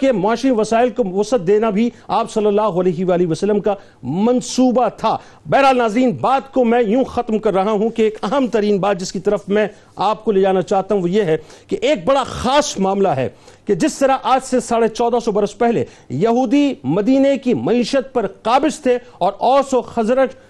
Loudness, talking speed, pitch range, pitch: -17 LUFS, 210 wpm, 205-255 Hz, 230 Hz